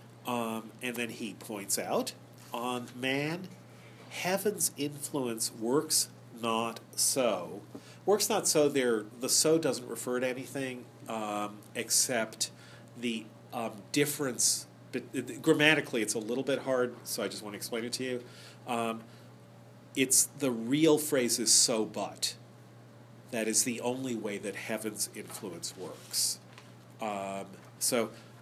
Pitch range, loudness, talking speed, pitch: 110-135 Hz, -31 LUFS, 135 wpm, 120 Hz